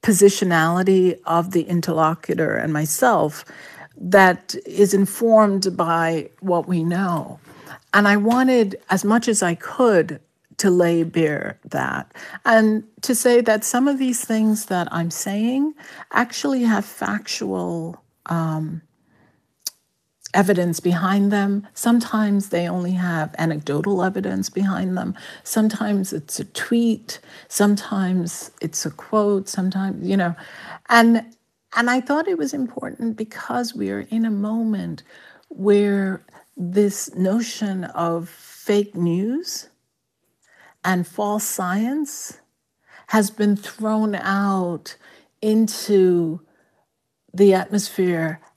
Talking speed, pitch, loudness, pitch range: 110 wpm, 200 Hz, -20 LUFS, 175-220 Hz